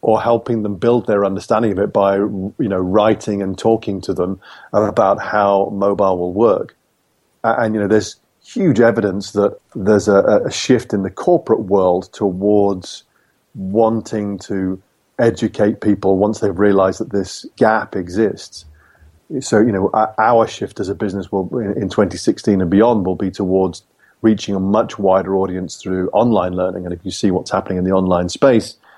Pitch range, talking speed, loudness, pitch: 95-105 Hz, 170 wpm, -16 LUFS, 100 Hz